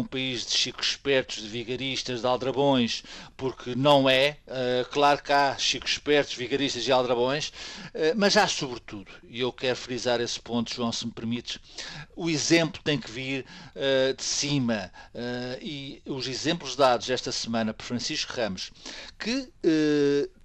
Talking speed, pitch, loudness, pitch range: 160 wpm, 130 Hz, -26 LUFS, 120-145 Hz